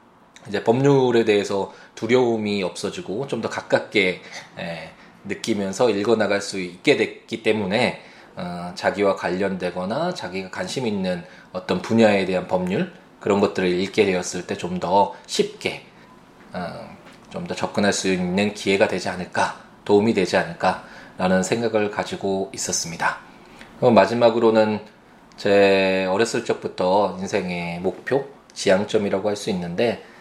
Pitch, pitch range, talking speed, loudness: 100 Hz, 95-115 Hz, 290 characters per minute, -22 LUFS